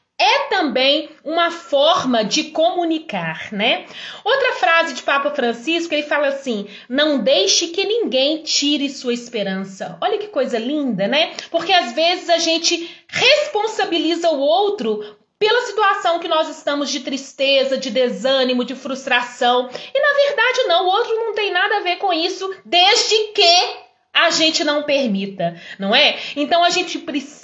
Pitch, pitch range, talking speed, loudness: 300 Hz, 265-350 Hz, 155 wpm, -17 LUFS